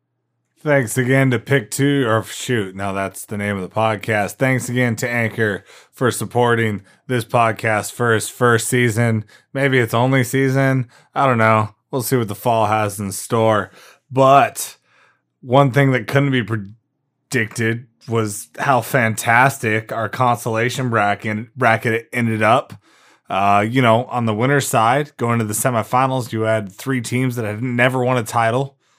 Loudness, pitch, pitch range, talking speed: -18 LUFS, 120 Hz, 110-130 Hz, 160 wpm